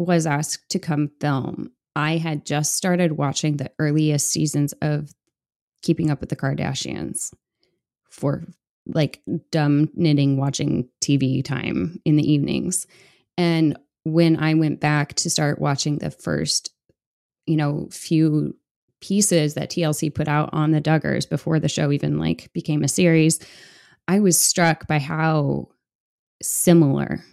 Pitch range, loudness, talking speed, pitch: 145-165 Hz, -21 LUFS, 140 wpm, 155 Hz